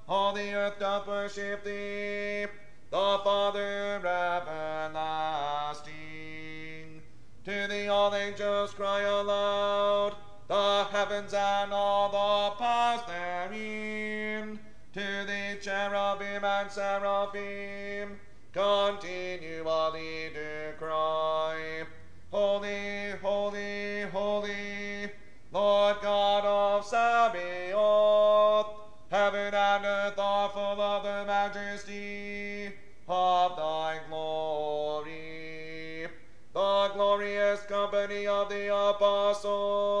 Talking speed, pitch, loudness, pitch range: 80 wpm, 200 Hz, -30 LUFS, 175-205 Hz